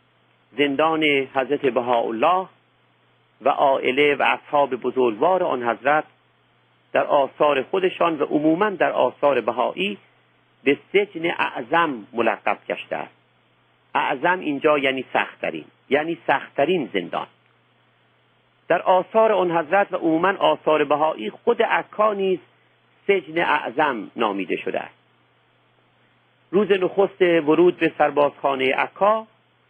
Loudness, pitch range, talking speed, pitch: -21 LUFS, 140-185 Hz, 105 wpm, 155 Hz